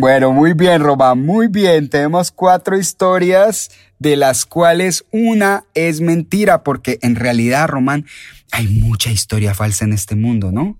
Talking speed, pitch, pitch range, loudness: 150 wpm, 145 Hz, 120-180 Hz, -14 LUFS